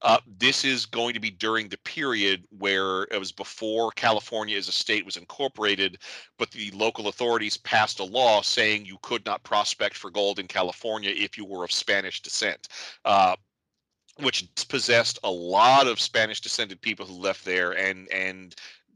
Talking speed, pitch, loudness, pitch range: 175 wpm, 105 Hz, -25 LUFS, 95-115 Hz